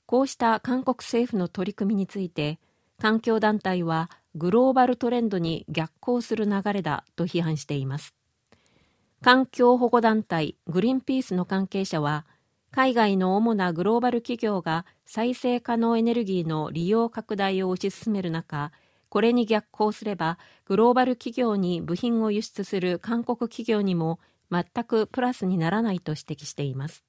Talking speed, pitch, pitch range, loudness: 255 characters per minute, 205 Hz, 170-235 Hz, -25 LUFS